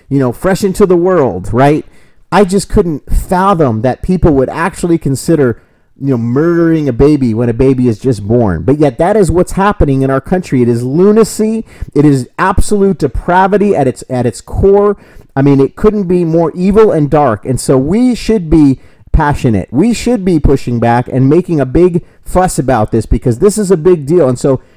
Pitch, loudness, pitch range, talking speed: 150 Hz, -10 LUFS, 130-185 Hz, 200 wpm